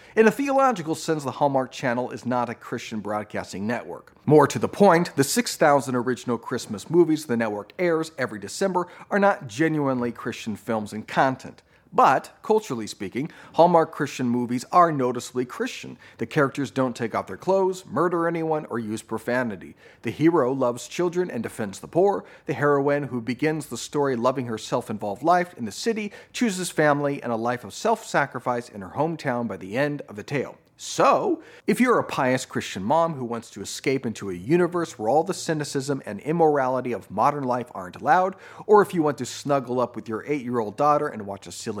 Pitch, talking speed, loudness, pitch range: 135 Hz, 195 wpm, -24 LUFS, 120-165 Hz